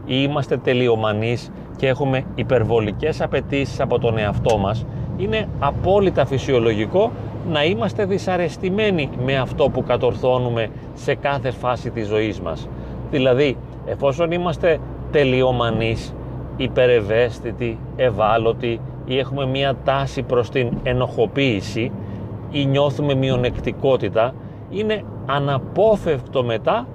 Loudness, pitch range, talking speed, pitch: -20 LUFS, 115-140 Hz, 100 wpm, 130 Hz